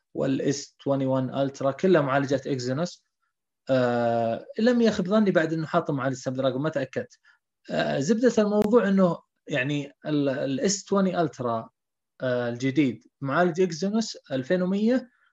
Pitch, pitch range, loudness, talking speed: 155 Hz, 135-195 Hz, -25 LUFS, 115 wpm